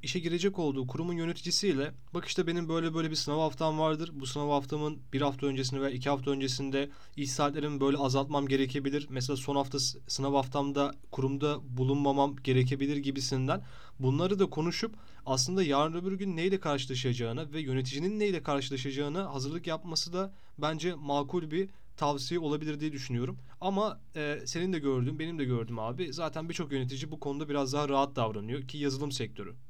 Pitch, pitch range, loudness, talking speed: 145 Hz, 135-160 Hz, -32 LUFS, 165 wpm